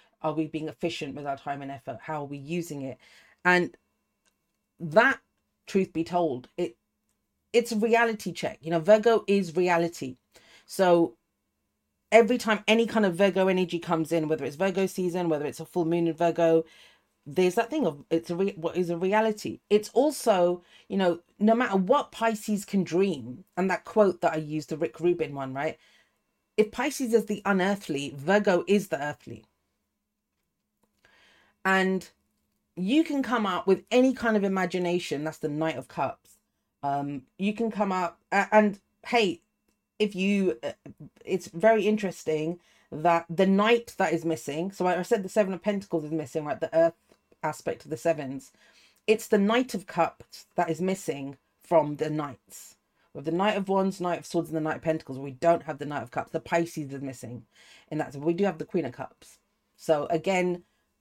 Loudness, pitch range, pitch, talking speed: -27 LUFS, 160-205 Hz, 175 Hz, 185 wpm